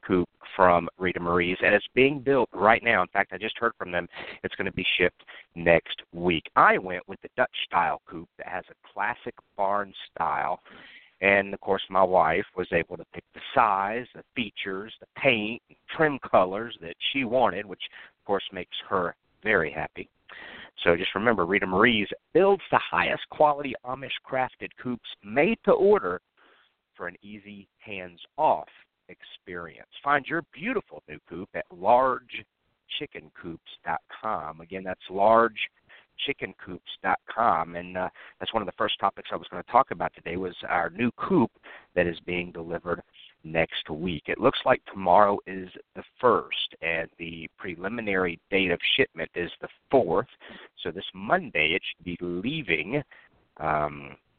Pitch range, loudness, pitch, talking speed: 85-115 Hz, -26 LUFS, 95 Hz, 155 wpm